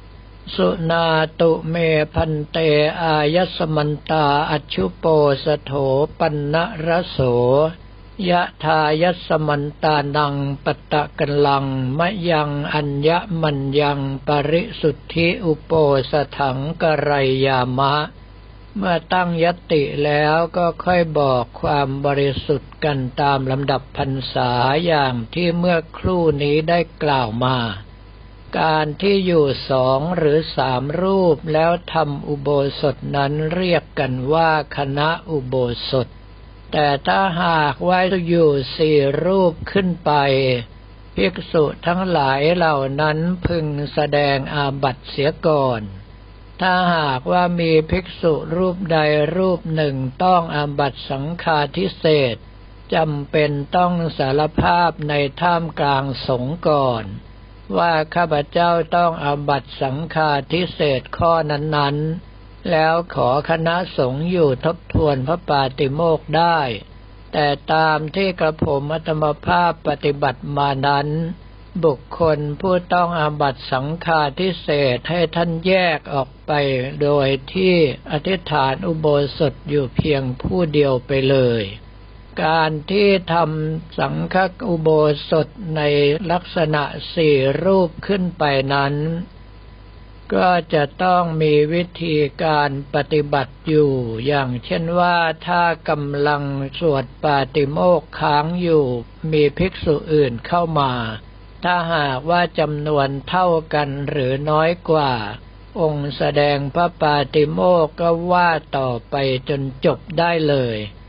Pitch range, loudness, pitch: 140-165 Hz, -19 LUFS, 150 Hz